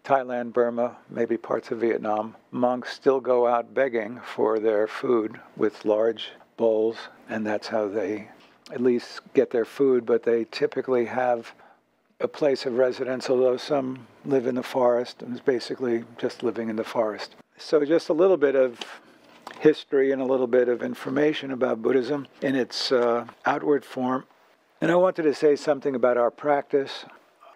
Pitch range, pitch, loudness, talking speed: 115-135 Hz, 125 Hz, -25 LUFS, 170 wpm